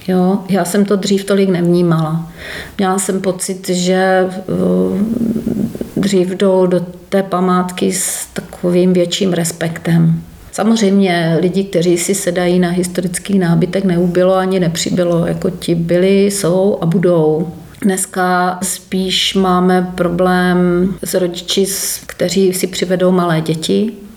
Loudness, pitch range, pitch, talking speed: -14 LUFS, 175-195 Hz, 185 Hz, 120 wpm